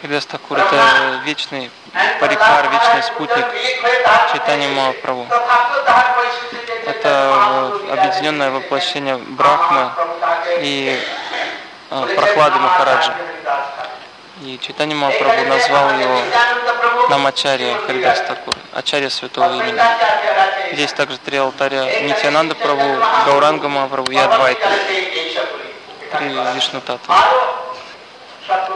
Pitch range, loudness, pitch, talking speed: 140-225 Hz, -15 LUFS, 165 Hz, 80 wpm